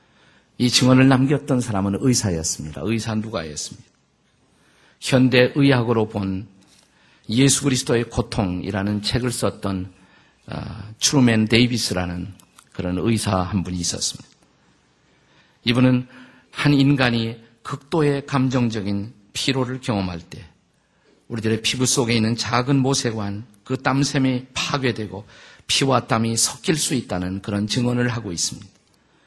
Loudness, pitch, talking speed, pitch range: -20 LUFS, 115 Hz, 275 characters per minute, 100-130 Hz